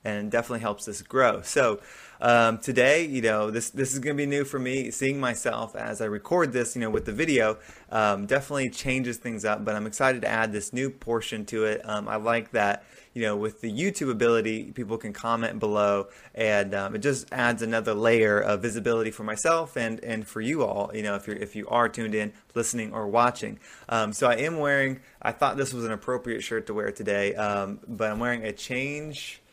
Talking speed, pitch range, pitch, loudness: 215 wpm, 105-125 Hz, 115 Hz, -27 LUFS